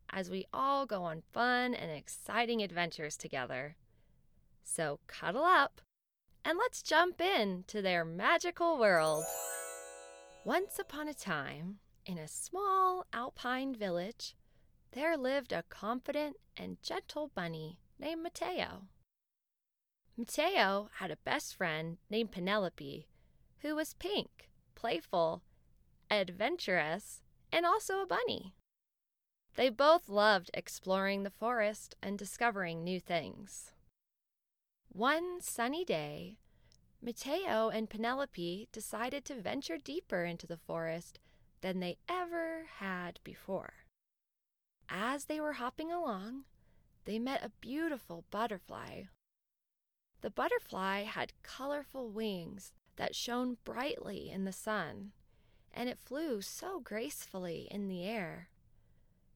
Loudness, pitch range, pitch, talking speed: -36 LUFS, 185-295 Hz, 220 Hz, 115 wpm